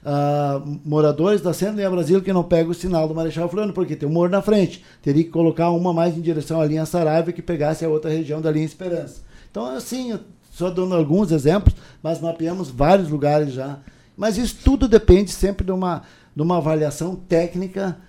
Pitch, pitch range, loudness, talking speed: 170 Hz, 155-185 Hz, -20 LUFS, 200 wpm